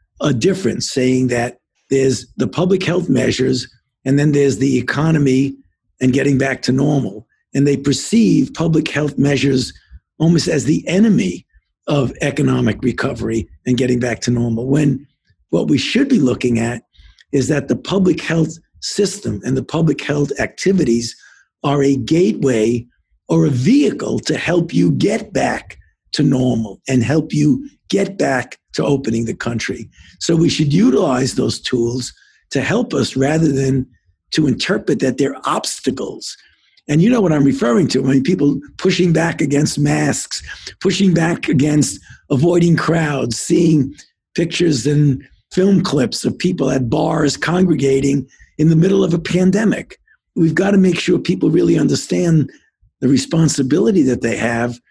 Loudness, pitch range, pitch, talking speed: -16 LUFS, 125-165 Hz, 140 Hz, 155 wpm